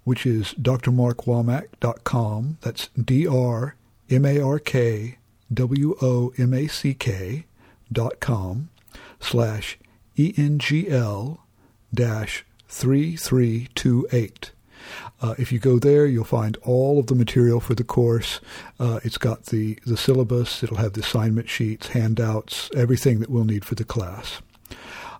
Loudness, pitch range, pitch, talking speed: -22 LUFS, 115-130 Hz, 120 Hz, 100 wpm